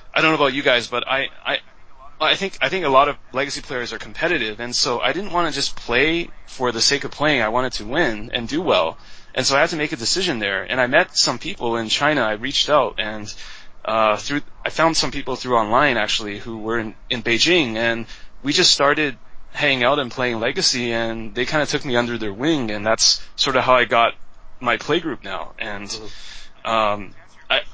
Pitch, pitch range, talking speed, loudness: 120 Hz, 110-140 Hz, 230 wpm, -19 LUFS